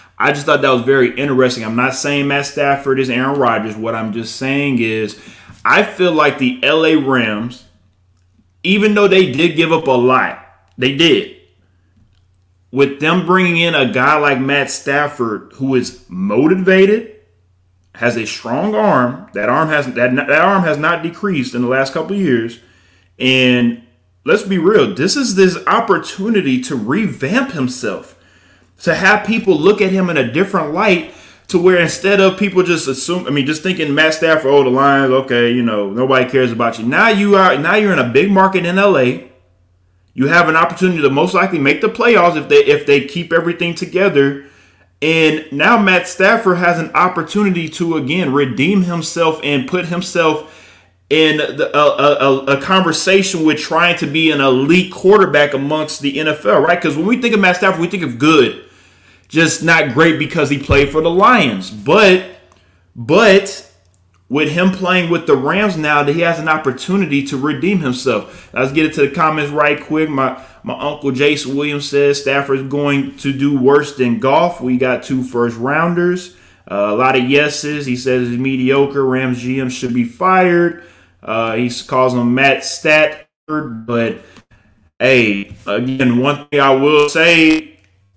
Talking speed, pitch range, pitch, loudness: 180 wpm, 125-170 Hz, 140 Hz, -13 LUFS